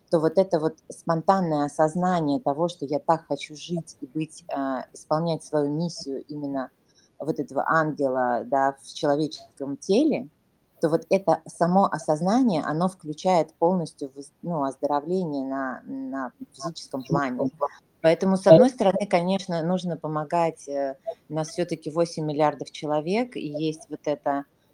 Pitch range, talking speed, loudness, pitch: 145-175 Hz, 140 wpm, -25 LUFS, 160 Hz